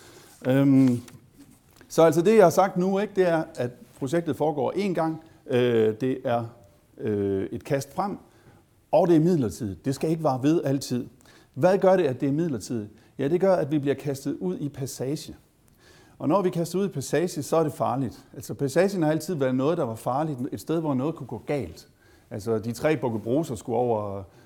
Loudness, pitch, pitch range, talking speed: -25 LUFS, 135 Hz, 120-160 Hz, 205 wpm